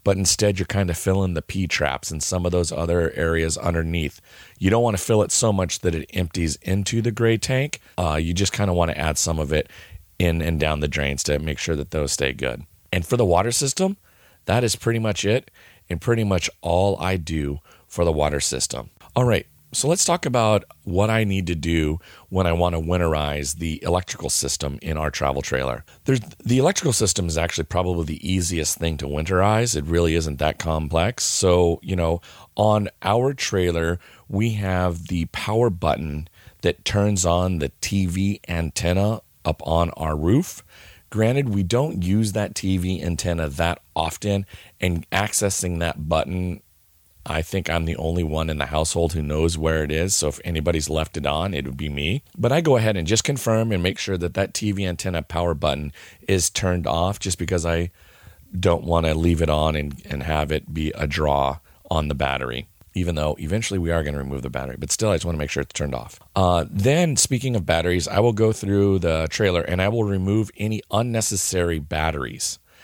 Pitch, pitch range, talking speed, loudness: 85 Hz, 80-100 Hz, 205 wpm, -22 LUFS